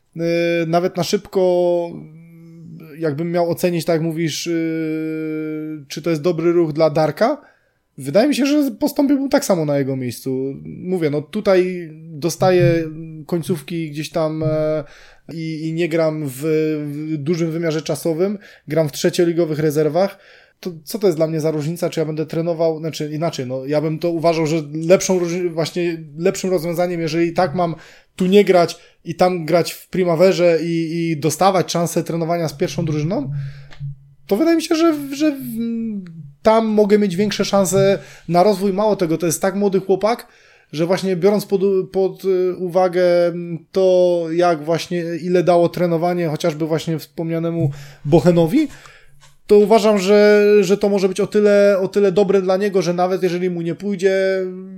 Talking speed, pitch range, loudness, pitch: 160 wpm, 160-190 Hz, -18 LUFS, 170 Hz